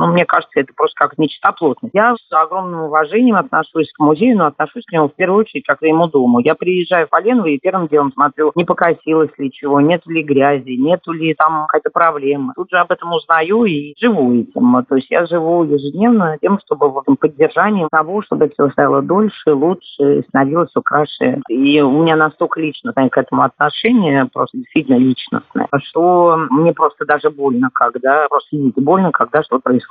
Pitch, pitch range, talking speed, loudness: 160 Hz, 145-180 Hz, 190 wpm, -14 LUFS